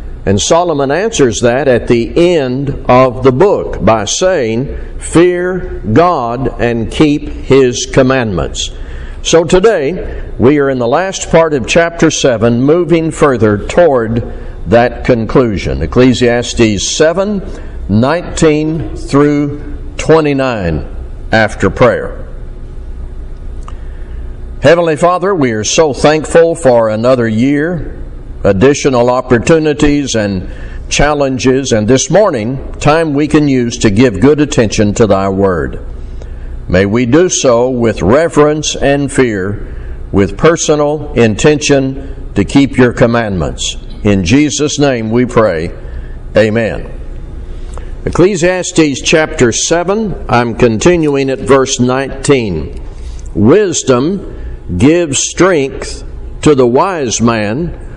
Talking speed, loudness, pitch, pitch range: 110 wpm, -10 LUFS, 125 Hz, 95-150 Hz